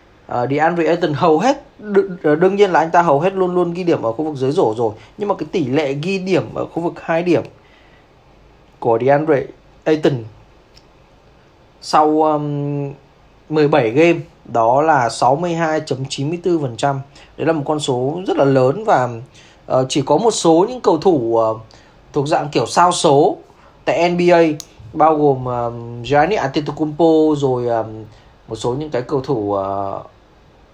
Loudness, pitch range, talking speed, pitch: -17 LUFS, 130-165 Hz, 165 wpm, 150 Hz